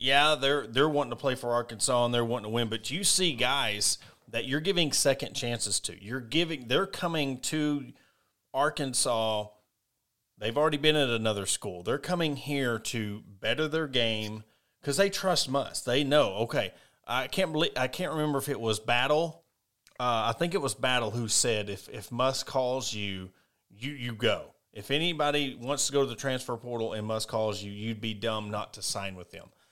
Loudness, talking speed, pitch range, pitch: -29 LUFS, 195 wpm, 110-145 Hz, 125 Hz